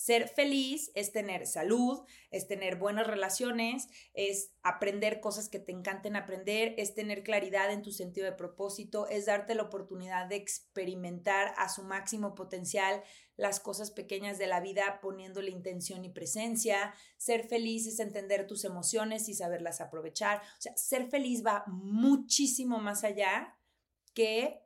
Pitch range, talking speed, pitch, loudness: 195-220 Hz, 150 wpm, 205 Hz, -34 LUFS